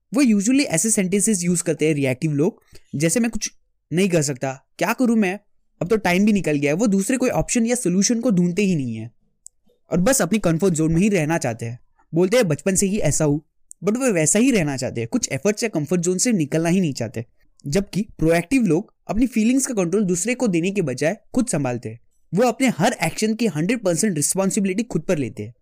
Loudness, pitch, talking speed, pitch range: -20 LUFS, 185 Hz, 225 wpm, 155-220 Hz